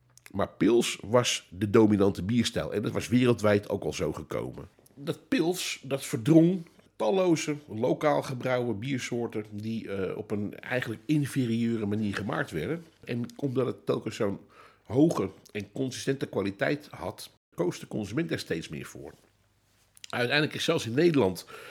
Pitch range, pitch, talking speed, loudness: 105-140 Hz, 120 Hz, 145 wpm, -28 LUFS